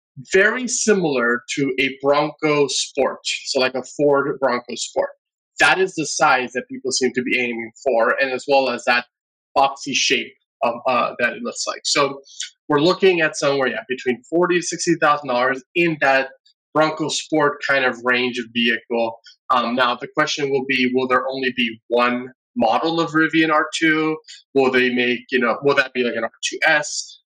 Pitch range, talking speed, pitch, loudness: 125-155 Hz, 180 wpm, 135 Hz, -19 LUFS